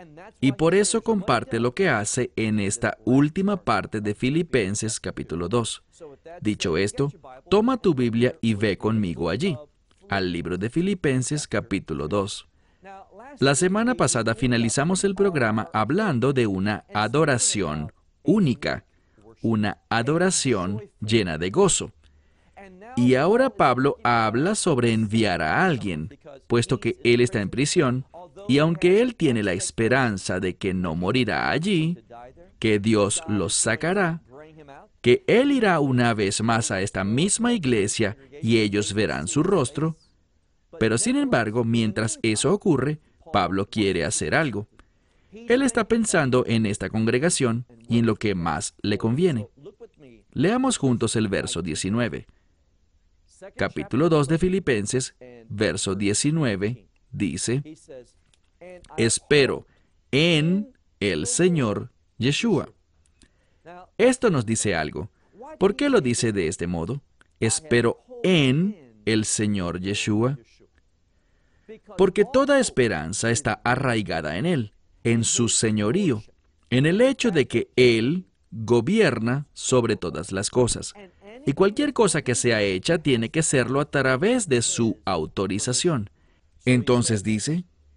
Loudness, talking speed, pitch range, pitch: -23 LUFS, 125 wpm, 105-160 Hz, 120 Hz